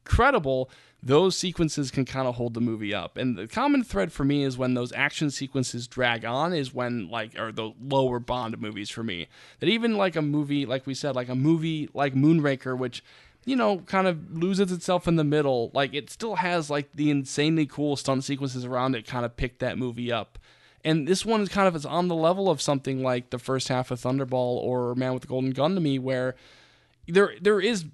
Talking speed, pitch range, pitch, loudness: 225 wpm, 125-160 Hz, 135 Hz, -26 LUFS